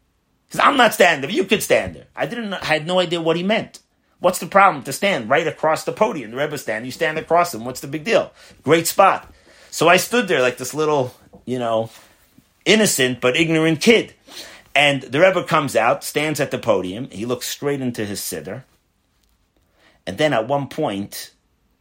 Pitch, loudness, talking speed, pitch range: 150 Hz, -18 LUFS, 205 wpm, 125-175 Hz